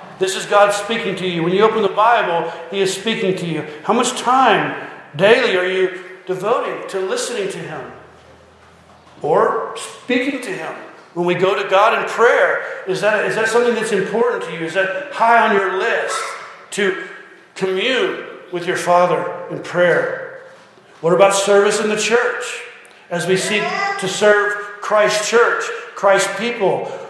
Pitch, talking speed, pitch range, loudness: 205 Hz, 165 wpm, 190-260 Hz, -17 LUFS